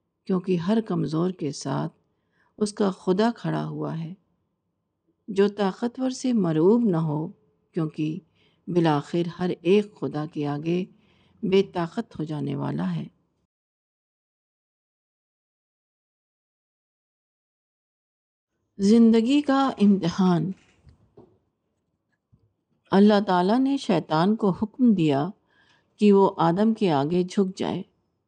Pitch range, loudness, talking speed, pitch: 165-210 Hz, -24 LUFS, 100 wpm, 185 Hz